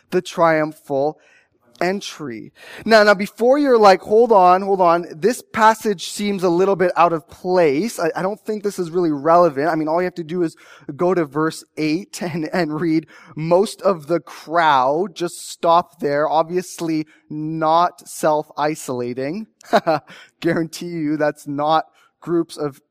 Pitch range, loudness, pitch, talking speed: 155-185 Hz, -18 LUFS, 170 Hz, 155 wpm